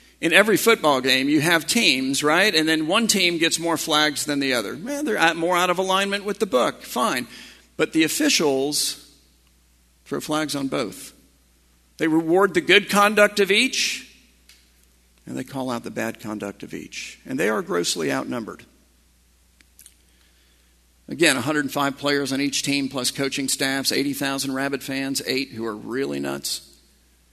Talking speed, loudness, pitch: 160 wpm, -21 LUFS, 140 Hz